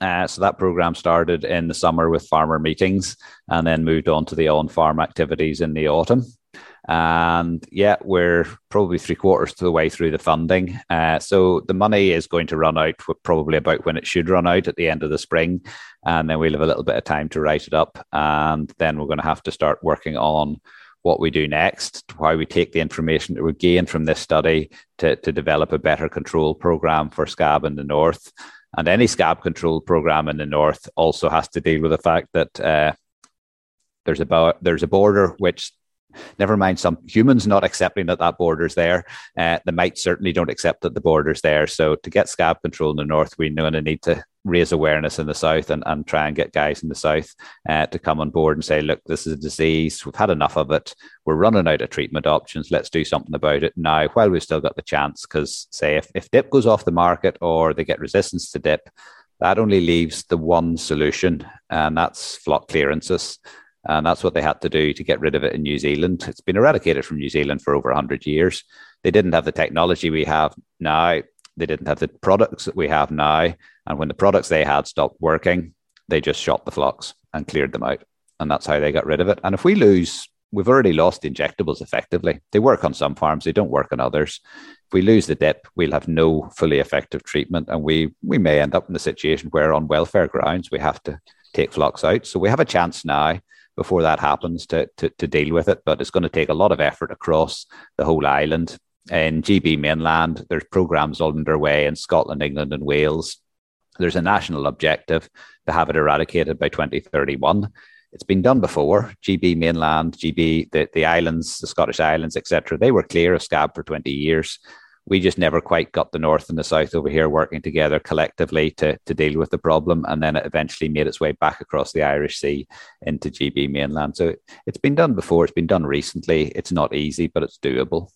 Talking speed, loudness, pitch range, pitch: 225 wpm, -19 LUFS, 75-85 Hz, 80 Hz